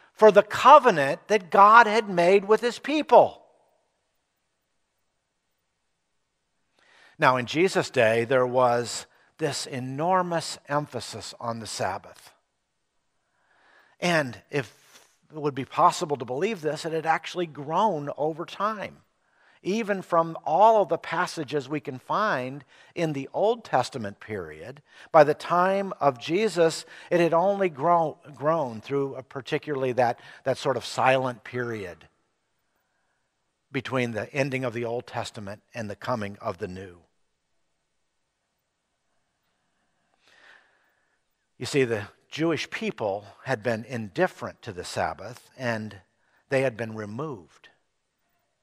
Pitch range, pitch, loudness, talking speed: 120-170 Hz, 140 Hz, -24 LUFS, 120 wpm